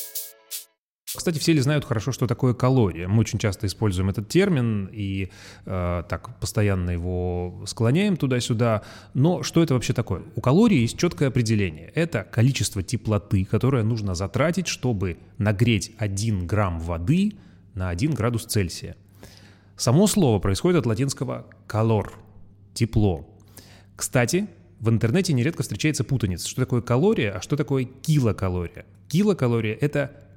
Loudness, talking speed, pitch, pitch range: -24 LUFS, 135 wpm, 110 Hz, 100-130 Hz